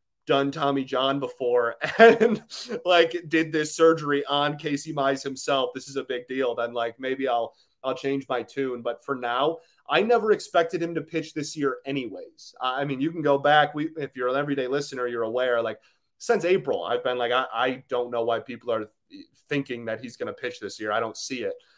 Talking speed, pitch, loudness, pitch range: 210 wpm, 140 Hz, -25 LUFS, 125-160 Hz